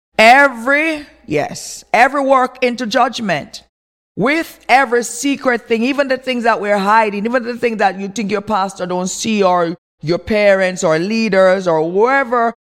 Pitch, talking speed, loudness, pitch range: 230 Hz, 155 wpm, -14 LUFS, 195-260 Hz